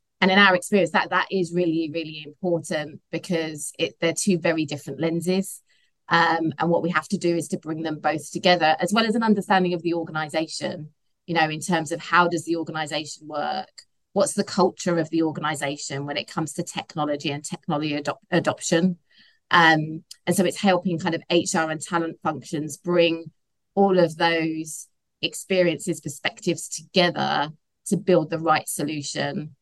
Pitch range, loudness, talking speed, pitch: 155-180 Hz, -23 LUFS, 175 wpm, 165 Hz